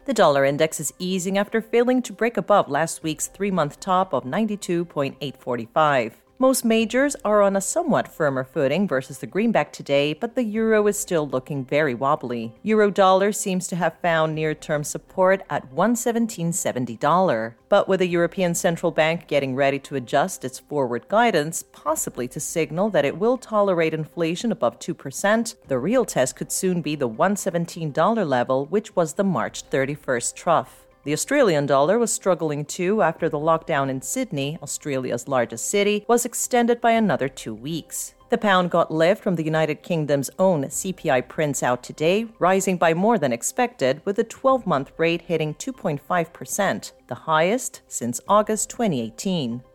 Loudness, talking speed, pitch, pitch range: -22 LUFS, 165 wpm, 170 Hz, 145-205 Hz